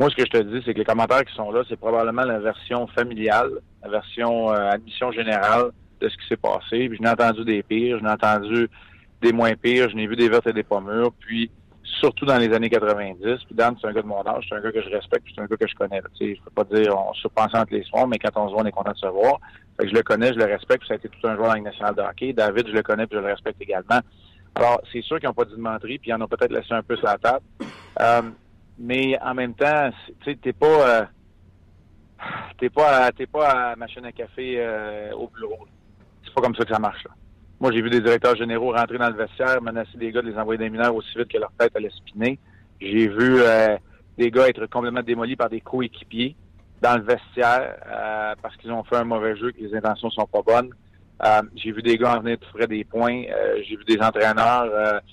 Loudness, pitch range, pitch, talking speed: -22 LUFS, 105-120 Hz, 115 Hz, 260 wpm